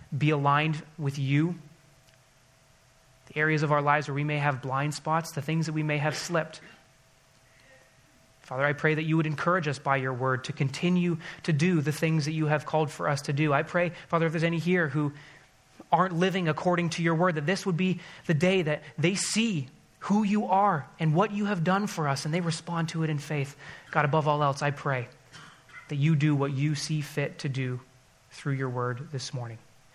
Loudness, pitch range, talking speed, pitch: -28 LUFS, 135-165 Hz, 215 wpm, 150 Hz